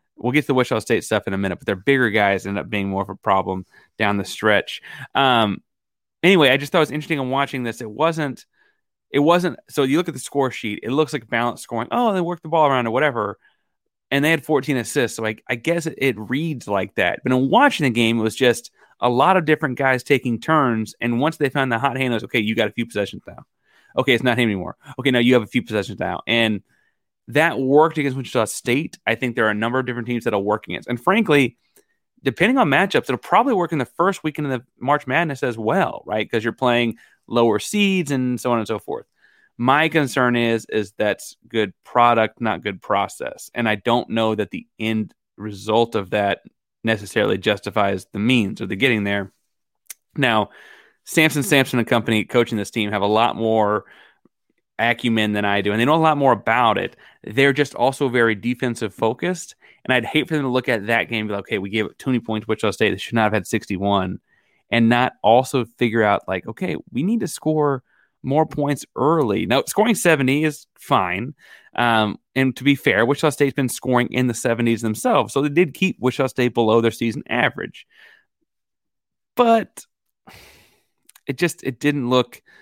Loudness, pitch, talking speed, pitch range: -20 LUFS, 125 Hz, 215 wpm, 110-145 Hz